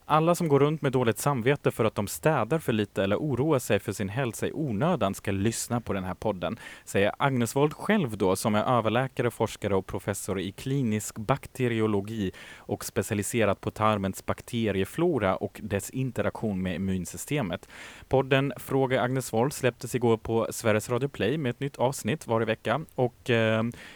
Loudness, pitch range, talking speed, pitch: -28 LUFS, 105-130 Hz, 175 wpm, 115 Hz